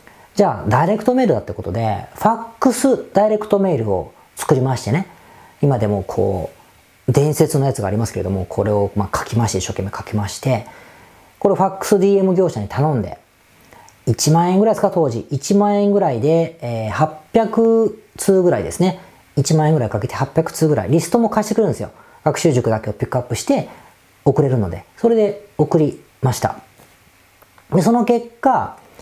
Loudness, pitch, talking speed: -18 LUFS, 155 Hz, 350 characters per minute